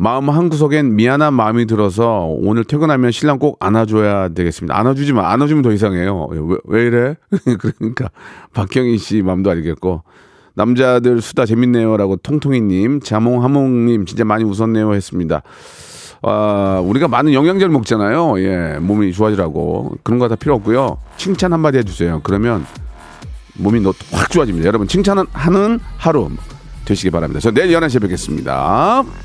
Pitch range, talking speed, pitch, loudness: 100-135 Hz, 360 characters per minute, 115 Hz, -15 LUFS